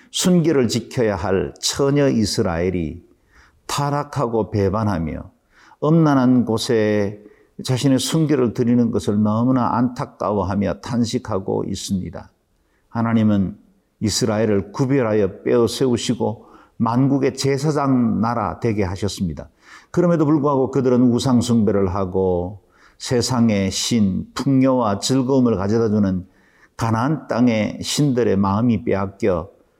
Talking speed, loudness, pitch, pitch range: 275 characters per minute, -19 LUFS, 115 Hz, 100-130 Hz